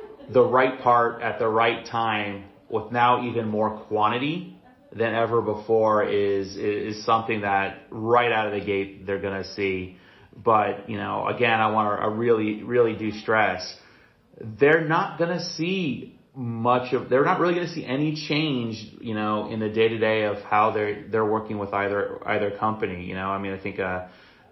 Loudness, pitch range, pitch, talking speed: -24 LUFS, 100-120 Hz, 110 Hz, 175 wpm